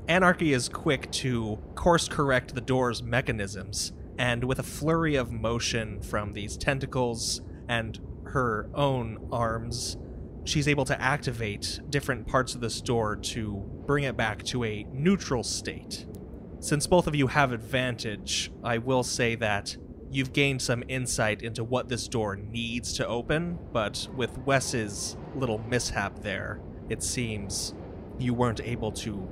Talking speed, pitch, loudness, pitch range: 145 wpm, 120 Hz, -29 LUFS, 105-130 Hz